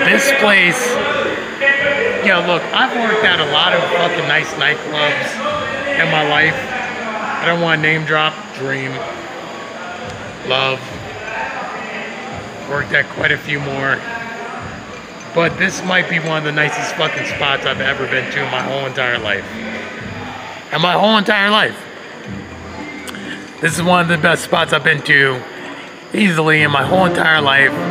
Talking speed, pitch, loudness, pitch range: 150 wpm, 160 Hz, -15 LUFS, 150-190 Hz